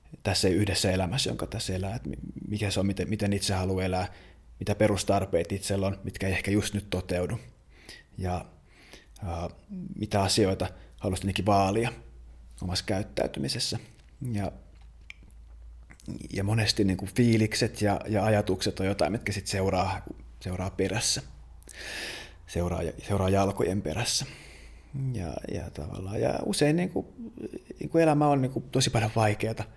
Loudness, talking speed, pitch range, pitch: -28 LUFS, 140 wpm, 90-110 Hz, 100 Hz